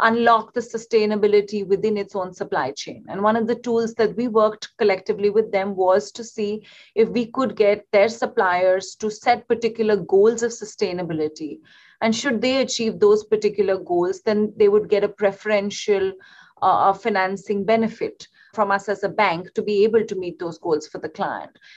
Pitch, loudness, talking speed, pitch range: 210 Hz, -21 LUFS, 180 wpm, 200-225 Hz